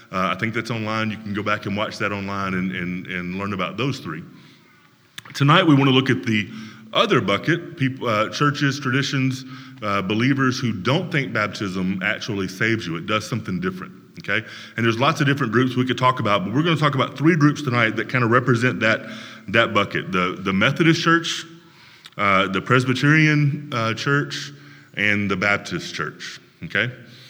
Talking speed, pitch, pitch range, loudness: 190 wpm, 120 Hz, 105-140 Hz, -21 LUFS